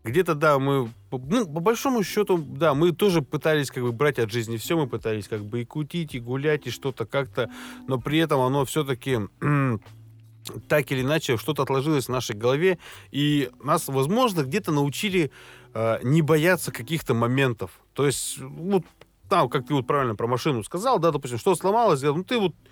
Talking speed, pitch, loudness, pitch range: 180 wpm, 140 Hz, -24 LUFS, 125-165 Hz